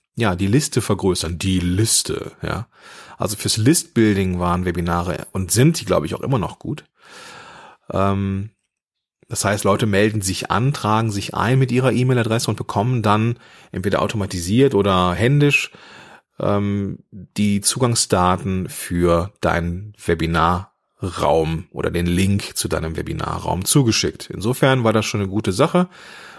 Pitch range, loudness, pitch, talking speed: 90-115 Hz, -19 LUFS, 100 Hz, 135 wpm